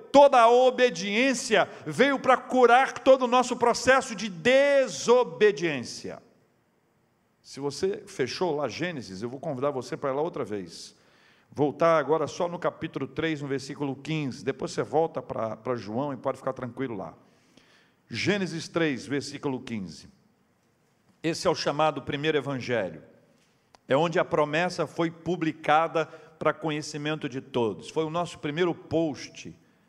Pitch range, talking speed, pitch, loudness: 140-205 Hz, 145 wpm, 160 Hz, -26 LUFS